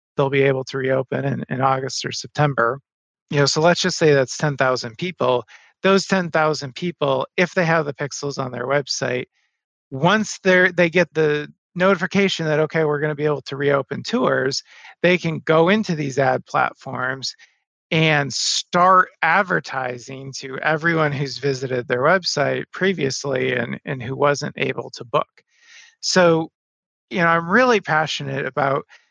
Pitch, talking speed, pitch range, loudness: 150 Hz, 165 wpm, 135-170 Hz, -20 LUFS